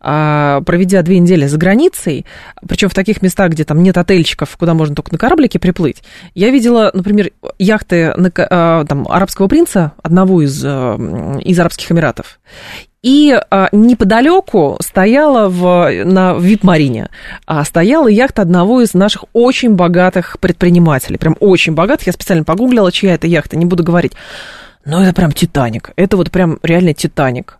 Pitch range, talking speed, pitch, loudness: 165-200 Hz, 150 wpm, 180 Hz, -11 LUFS